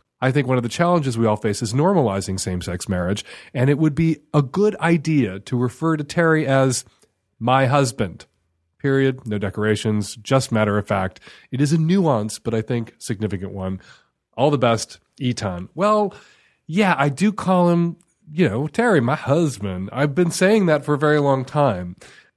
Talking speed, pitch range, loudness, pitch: 180 wpm, 105-155 Hz, -20 LUFS, 135 Hz